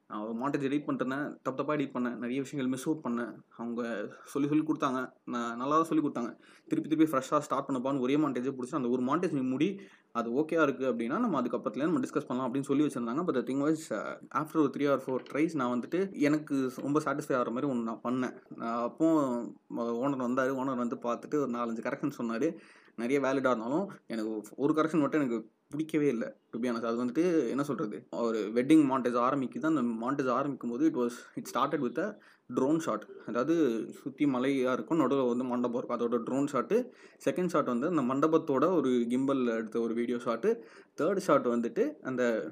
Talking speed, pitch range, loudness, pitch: 190 wpm, 120-150 Hz, -31 LUFS, 130 Hz